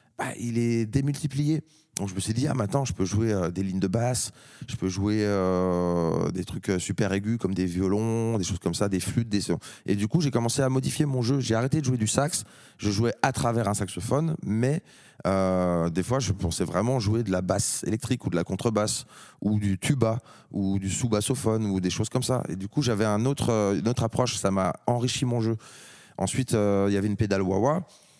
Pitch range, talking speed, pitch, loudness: 95-130 Hz, 230 wpm, 110 Hz, -26 LUFS